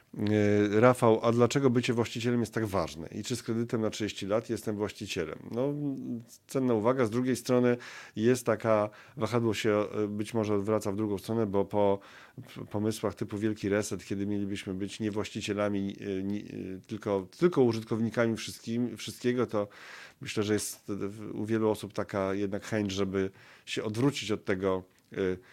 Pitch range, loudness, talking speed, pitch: 100-115 Hz, -30 LUFS, 150 wpm, 105 Hz